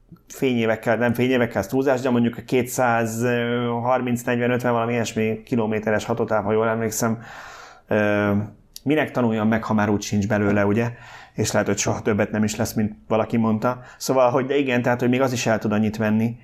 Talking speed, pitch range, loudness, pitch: 175 wpm, 110-125 Hz, -22 LUFS, 115 Hz